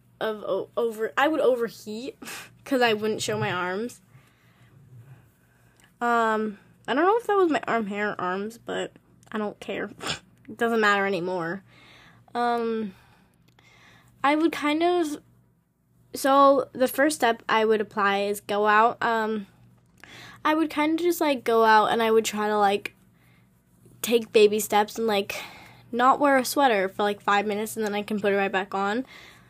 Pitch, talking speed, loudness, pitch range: 220 Hz, 170 wpm, -24 LUFS, 200-250 Hz